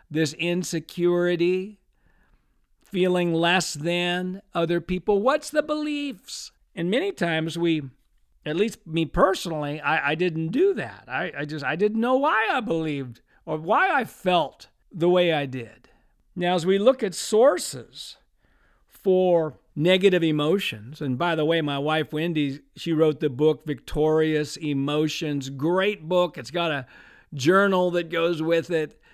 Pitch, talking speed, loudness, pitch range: 170 Hz, 150 wpm, -24 LUFS, 155-185 Hz